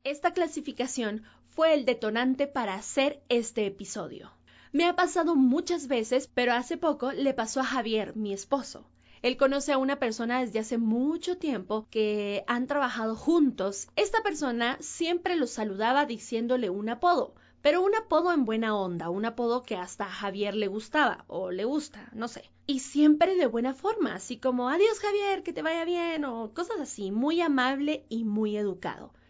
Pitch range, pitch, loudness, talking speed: 220-305 Hz, 255 Hz, -28 LUFS, 170 wpm